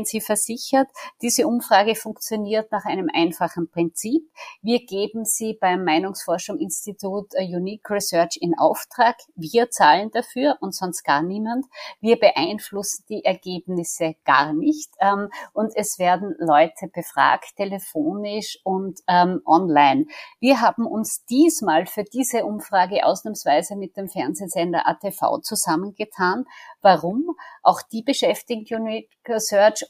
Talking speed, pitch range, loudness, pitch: 120 wpm, 180-230 Hz, -21 LUFS, 205 Hz